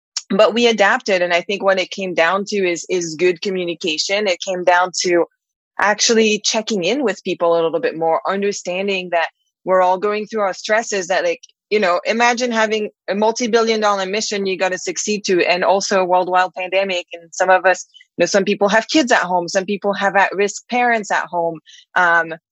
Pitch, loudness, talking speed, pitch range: 195 Hz, -17 LUFS, 205 wpm, 180-215 Hz